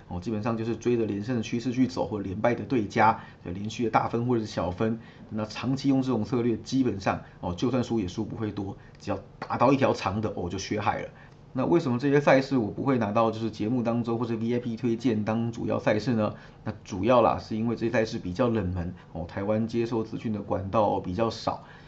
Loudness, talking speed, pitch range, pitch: -27 LUFS, 345 characters per minute, 110-120 Hz, 115 Hz